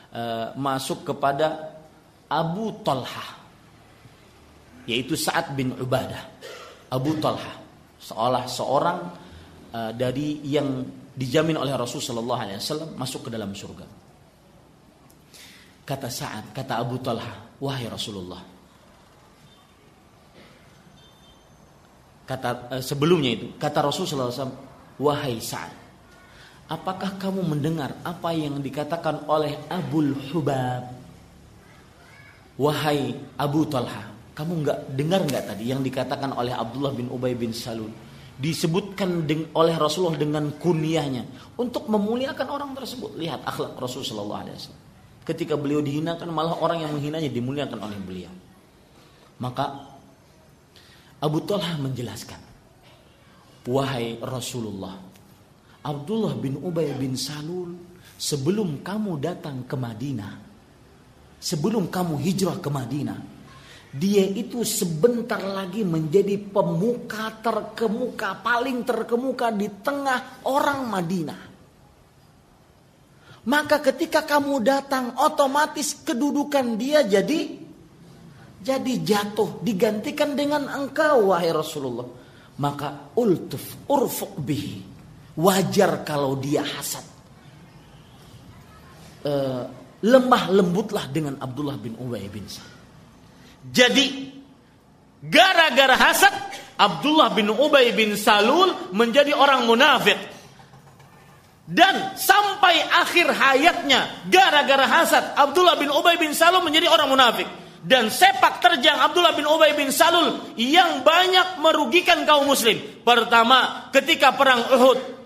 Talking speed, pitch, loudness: 100 wpm, 165 Hz, -22 LUFS